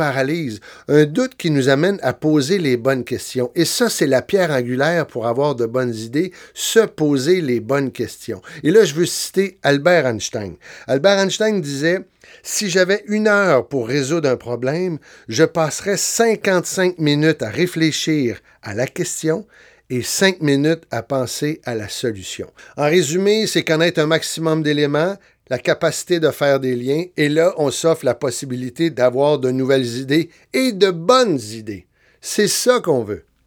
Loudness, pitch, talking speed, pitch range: -18 LUFS, 155 Hz, 165 wpm, 135-180 Hz